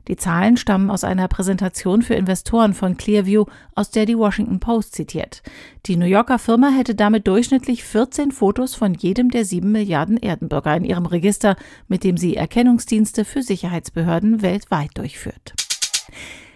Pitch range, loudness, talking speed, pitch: 185-230 Hz, -18 LUFS, 150 wpm, 205 Hz